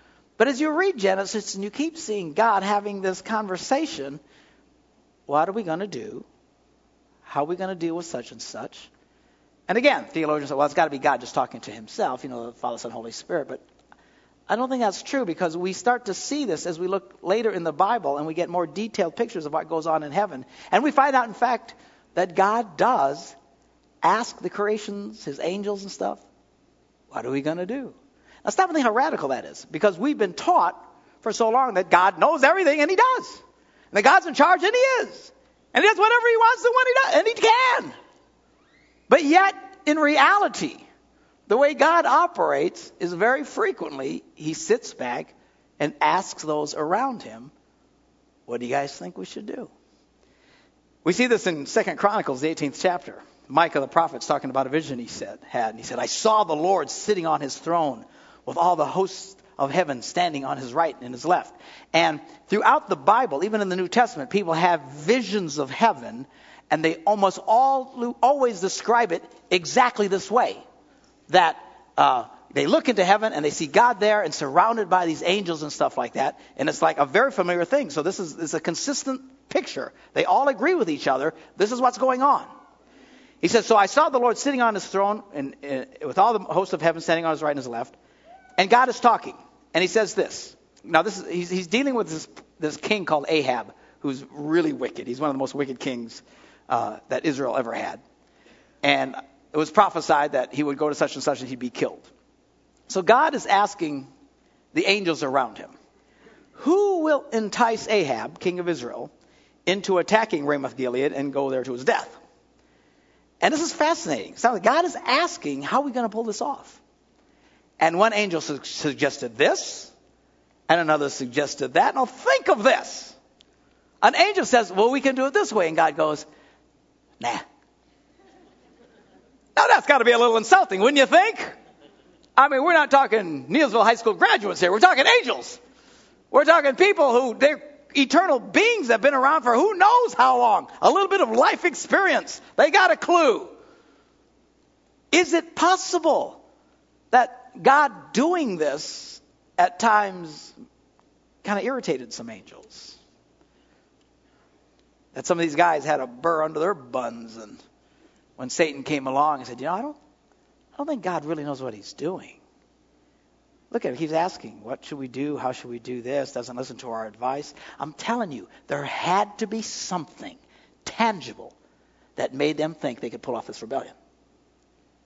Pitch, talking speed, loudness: 200 Hz, 190 wpm, -22 LUFS